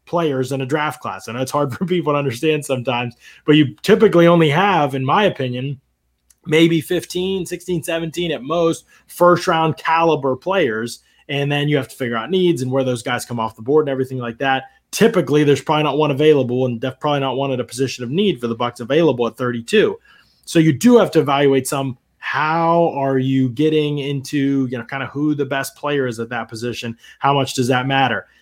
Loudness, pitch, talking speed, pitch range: -18 LUFS, 140 Hz, 215 wpm, 130-165 Hz